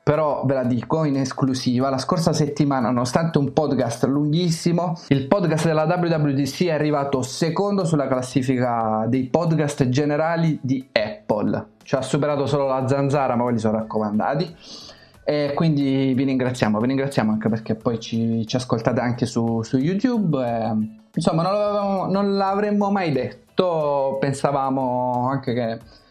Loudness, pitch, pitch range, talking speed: -21 LUFS, 140 Hz, 125-160 Hz, 150 wpm